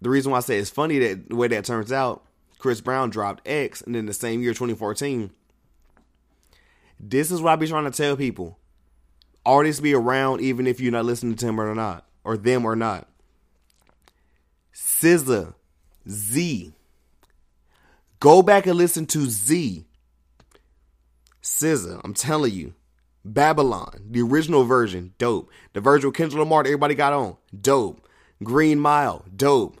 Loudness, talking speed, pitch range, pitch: -21 LUFS, 155 wpm, 90-140 Hz, 120 Hz